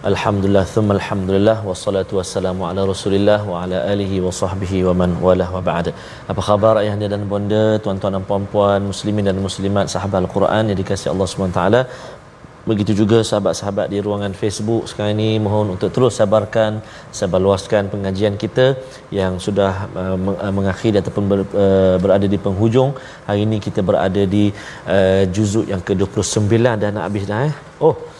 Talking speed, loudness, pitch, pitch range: 165 wpm, -17 LUFS, 100 Hz, 95-105 Hz